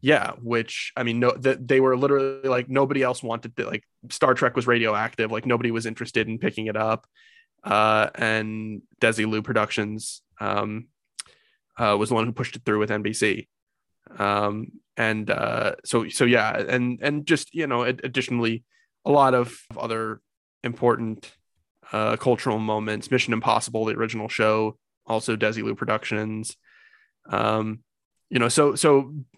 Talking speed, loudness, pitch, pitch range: 155 wpm, -24 LUFS, 115 Hz, 110-125 Hz